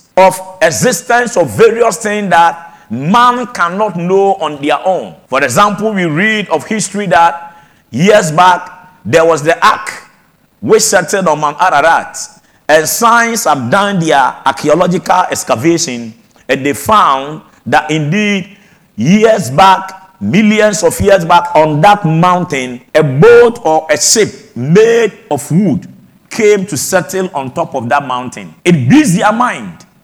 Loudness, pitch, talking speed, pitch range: -10 LUFS, 180 Hz, 140 wpm, 155-205 Hz